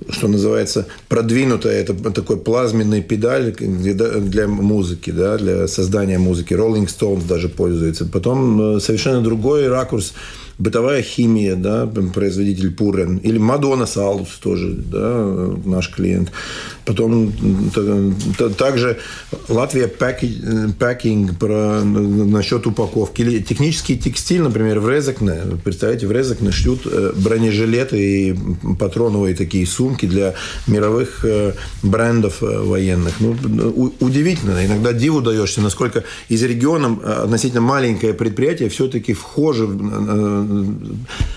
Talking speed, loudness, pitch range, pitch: 105 wpm, -17 LUFS, 100-120 Hz, 110 Hz